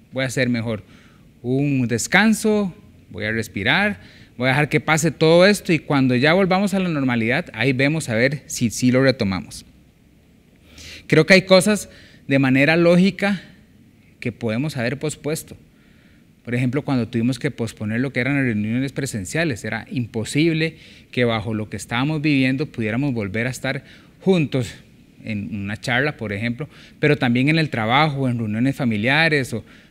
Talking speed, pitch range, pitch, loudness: 165 wpm, 115-155 Hz, 130 Hz, -20 LUFS